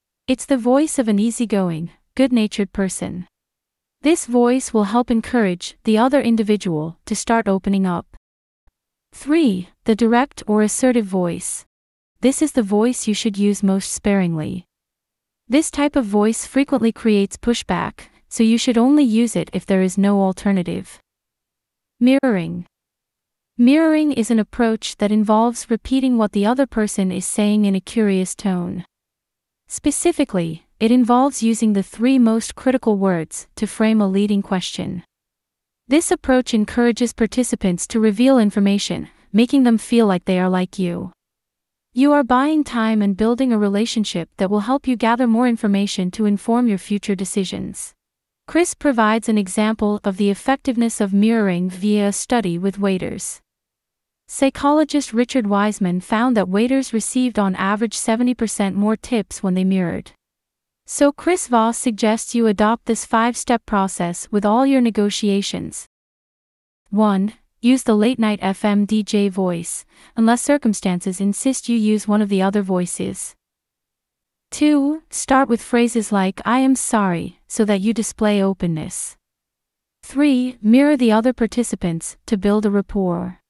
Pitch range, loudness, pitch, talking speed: 195-245 Hz, -18 LUFS, 220 Hz, 145 wpm